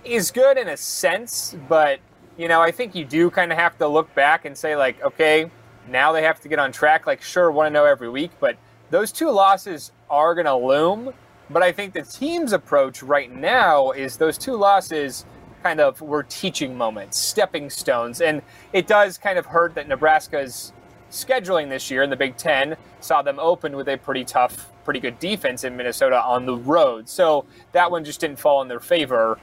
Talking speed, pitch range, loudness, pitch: 210 wpm, 130-180 Hz, -20 LUFS, 155 Hz